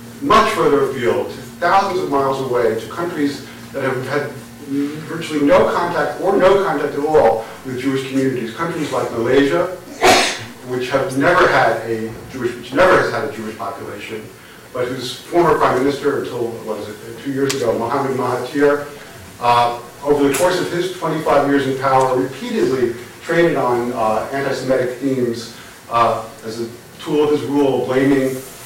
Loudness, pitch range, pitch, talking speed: -17 LUFS, 120-145 Hz, 135 Hz, 155 wpm